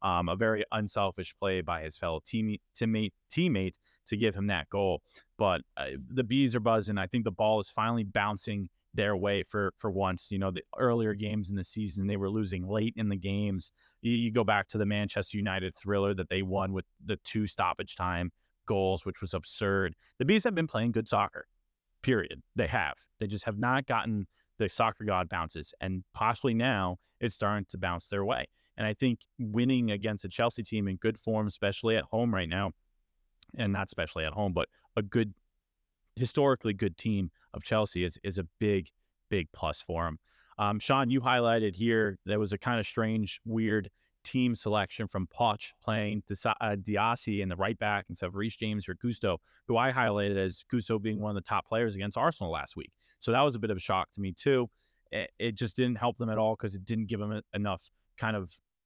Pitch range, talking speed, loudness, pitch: 95-115 Hz, 210 wpm, -32 LUFS, 105 Hz